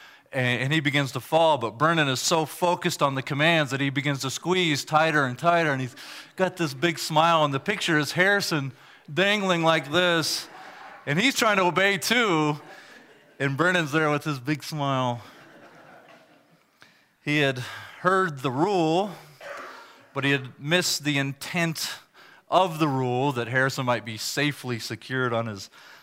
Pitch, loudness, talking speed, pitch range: 150 Hz, -24 LUFS, 160 wpm, 135-170 Hz